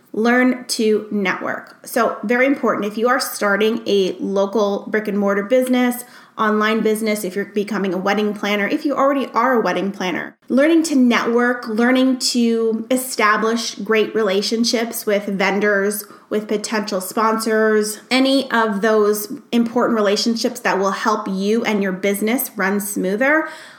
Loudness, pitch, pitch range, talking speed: -18 LUFS, 220 Hz, 205-245 Hz, 145 wpm